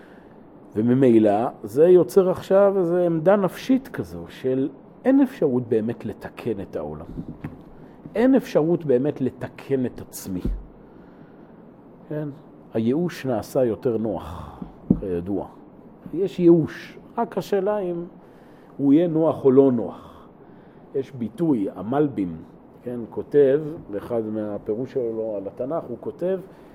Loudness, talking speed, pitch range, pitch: -22 LUFS, 110 wpm, 115-180 Hz, 135 Hz